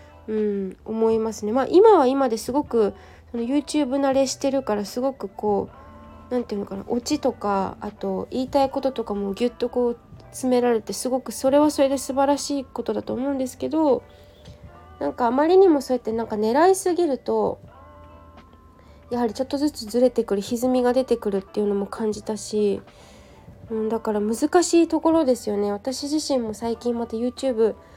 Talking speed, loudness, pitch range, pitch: 385 characters per minute, -23 LUFS, 210-270 Hz, 235 Hz